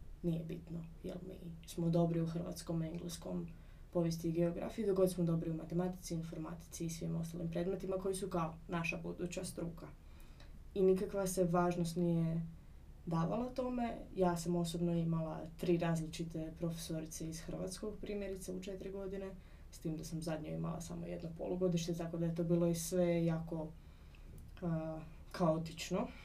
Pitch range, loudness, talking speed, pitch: 165-185 Hz, -39 LUFS, 155 wpm, 170 Hz